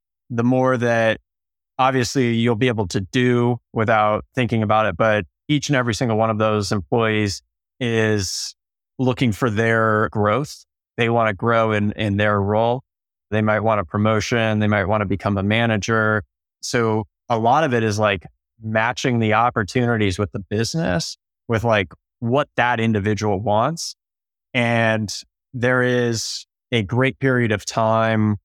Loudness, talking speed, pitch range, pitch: -20 LUFS, 155 wpm, 105-120 Hz, 110 Hz